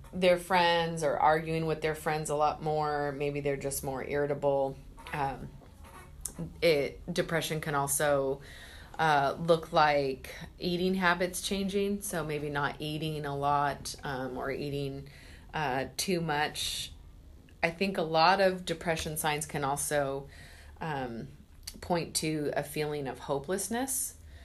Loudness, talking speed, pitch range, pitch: -31 LUFS, 135 wpm, 140-165 Hz, 150 Hz